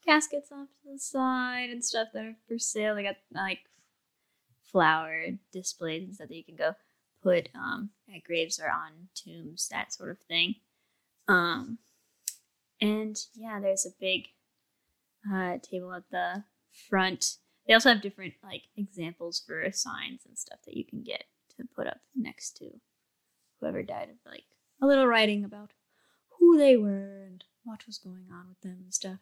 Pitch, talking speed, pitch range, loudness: 205 Hz, 170 wpm, 185-240 Hz, -29 LUFS